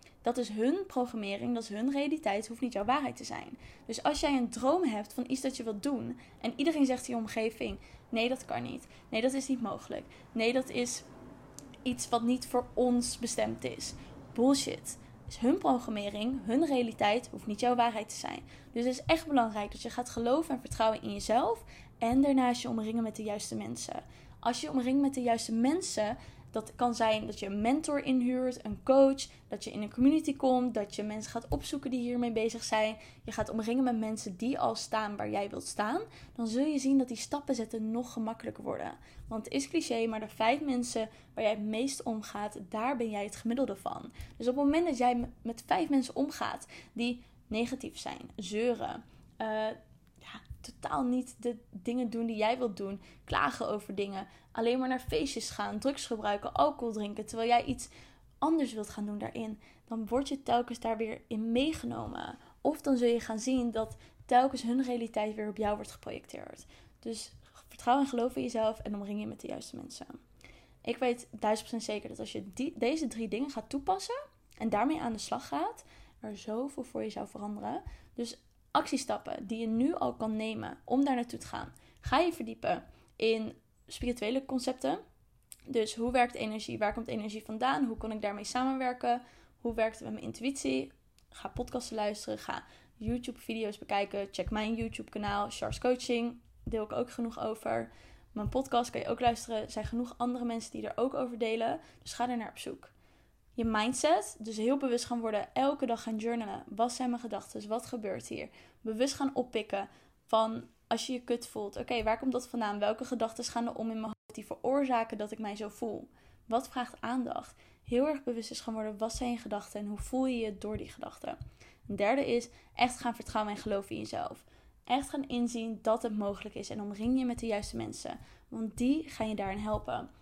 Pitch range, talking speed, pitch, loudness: 220-255 Hz, 205 wpm, 235 Hz, -34 LUFS